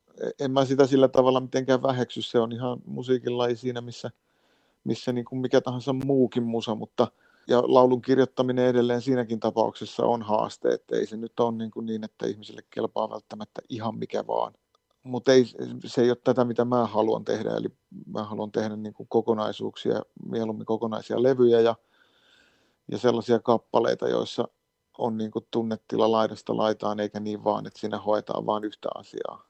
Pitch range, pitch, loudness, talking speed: 110-125 Hz, 120 Hz, -26 LUFS, 170 wpm